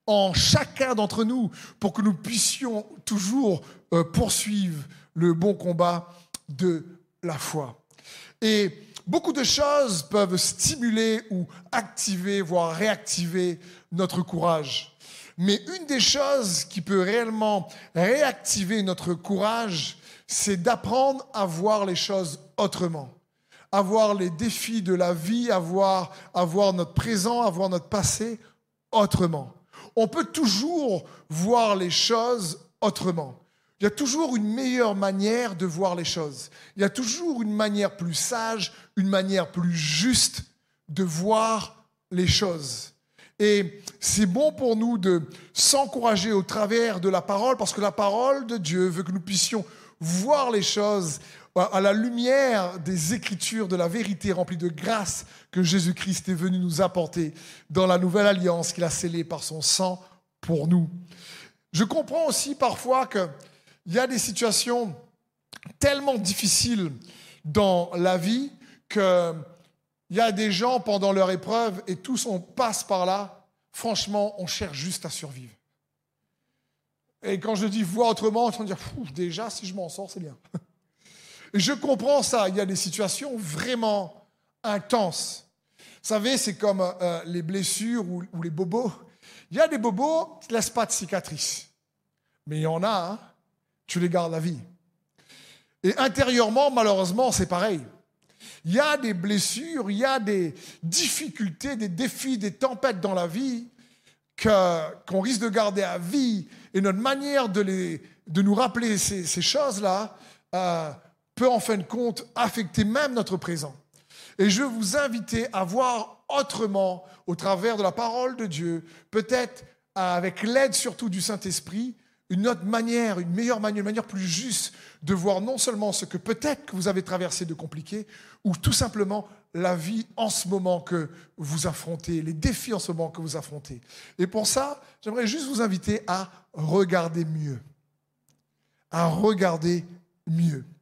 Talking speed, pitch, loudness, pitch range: 160 wpm, 195 Hz, -25 LUFS, 175-225 Hz